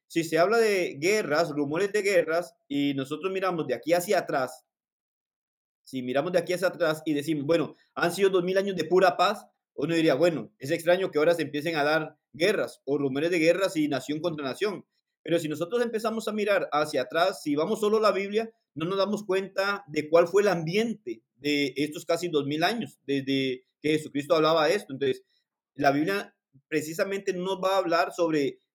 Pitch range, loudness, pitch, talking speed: 150-195 Hz, -27 LUFS, 170 Hz, 200 wpm